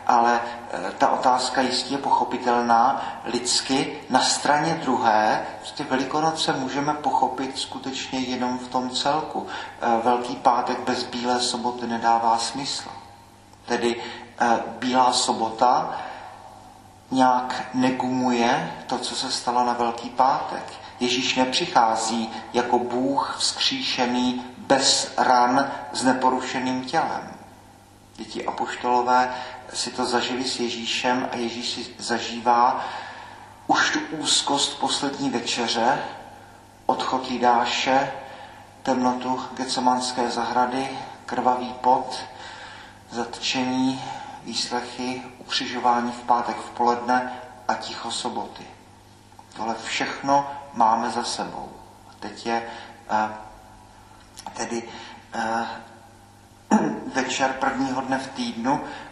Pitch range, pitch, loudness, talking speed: 115-130 Hz, 125 Hz, -23 LUFS, 95 wpm